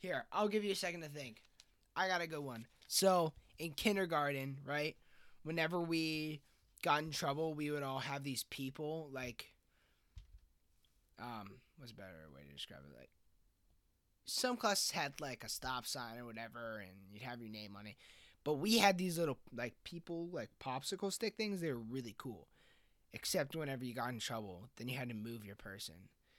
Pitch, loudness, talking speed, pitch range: 130 Hz, -40 LUFS, 185 wpm, 110-160 Hz